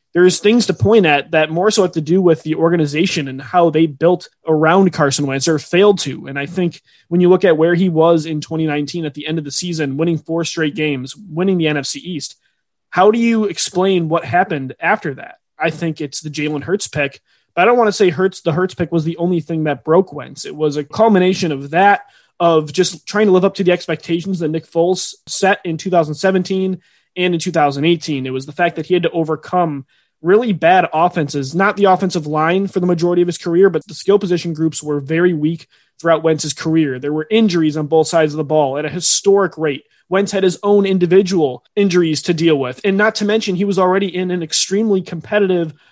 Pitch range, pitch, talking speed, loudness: 155-185 Hz, 170 Hz, 225 wpm, -16 LUFS